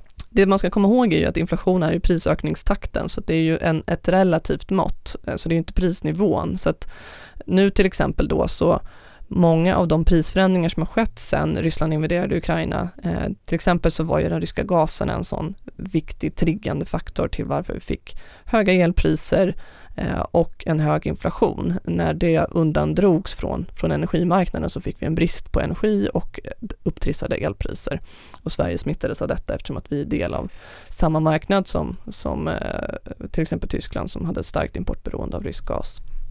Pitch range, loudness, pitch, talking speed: 155-190 Hz, -21 LUFS, 170 Hz, 185 wpm